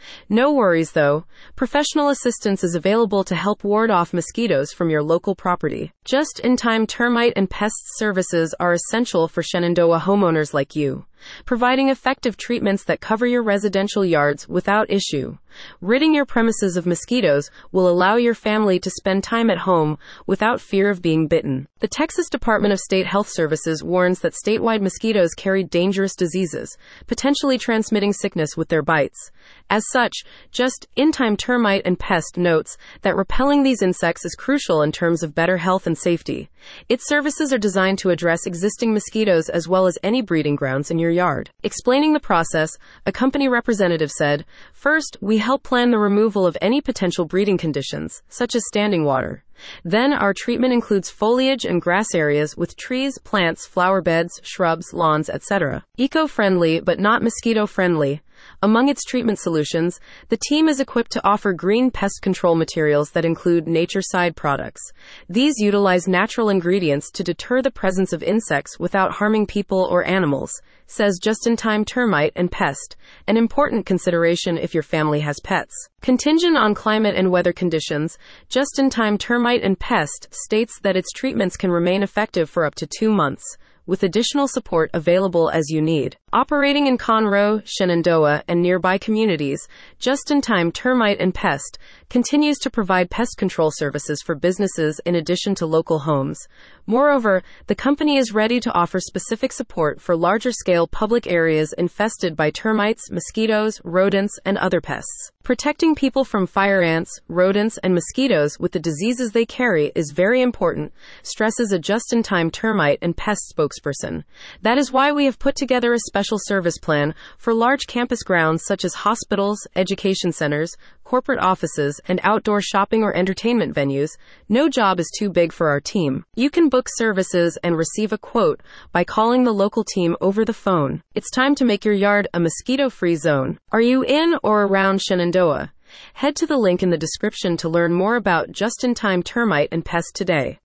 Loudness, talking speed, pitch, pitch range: -19 LUFS, 170 wpm, 195 Hz, 170-235 Hz